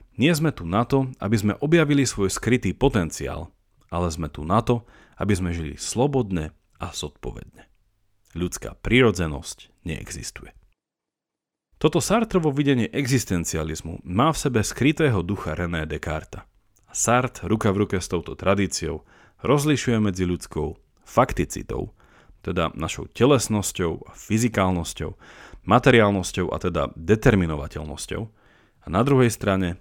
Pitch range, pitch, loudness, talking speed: 85-120 Hz, 100 Hz, -23 LUFS, 120 wpm